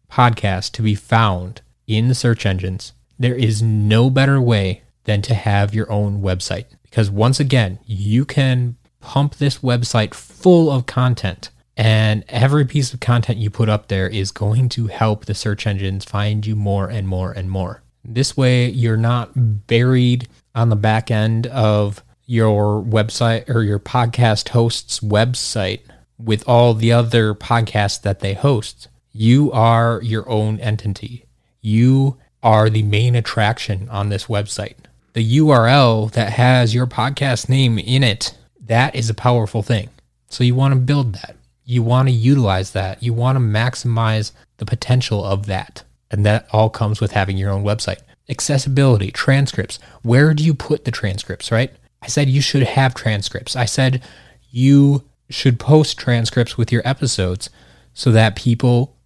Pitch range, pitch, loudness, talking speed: 105-125 Hz, 115 Hz, -17 LUFS, 165 wpm